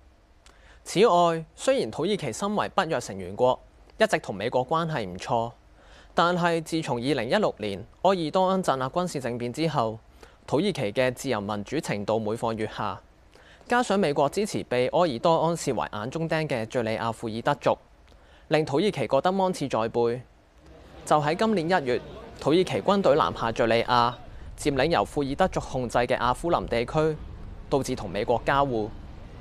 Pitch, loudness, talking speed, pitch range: 125 Hz, -26 LUFS, 265 characters per minute, 110-160 Hz